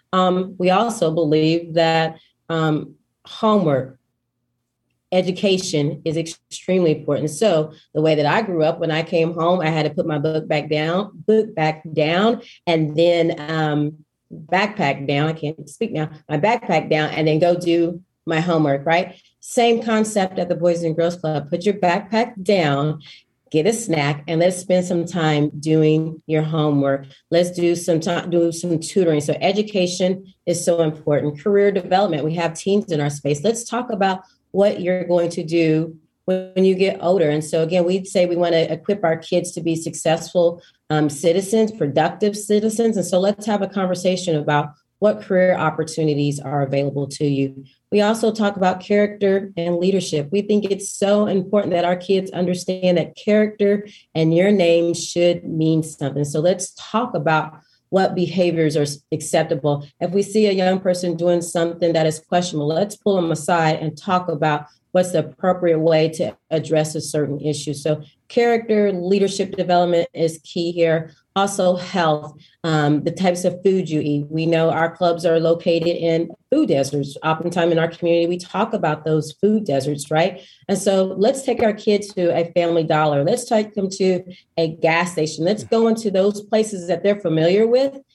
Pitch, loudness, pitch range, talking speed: 170 Hz, -19 LUFS, 155-190 Hz, 175 wpm